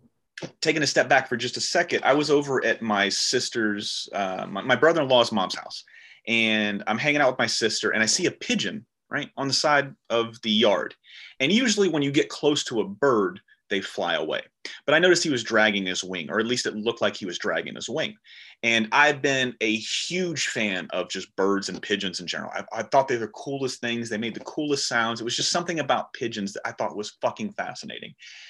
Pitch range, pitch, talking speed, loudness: 110-145 Hz, 115 Hz, 225 wpm, -24 LUFS